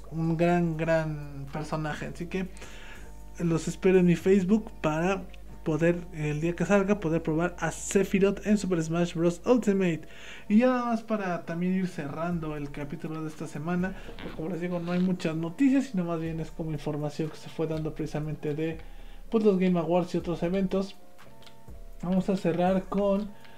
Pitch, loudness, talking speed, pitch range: 170 Hz, -28 LUFS, 180 wpm, 160-190 Hz